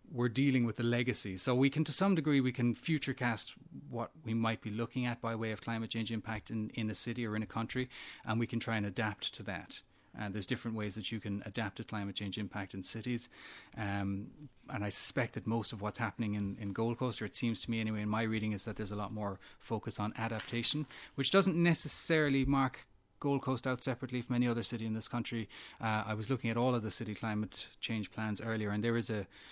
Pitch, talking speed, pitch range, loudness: 115 Hz, 245 wpm, 105-125 Hz, -36 LUFS